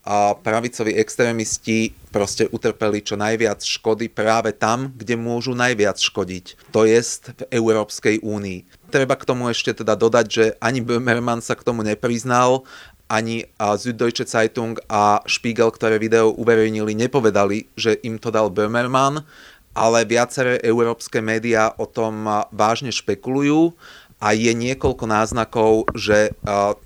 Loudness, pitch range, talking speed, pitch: -19 LUFS, 105-120 Hz, 135 wpm, 110 Hz